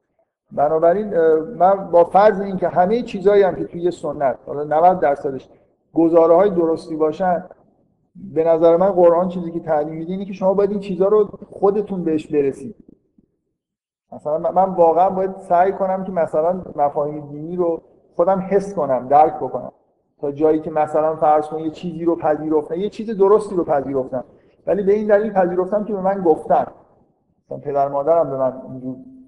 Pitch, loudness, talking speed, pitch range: 170 Hz, -18 LUFS, 165 wpm, 155-195 Hz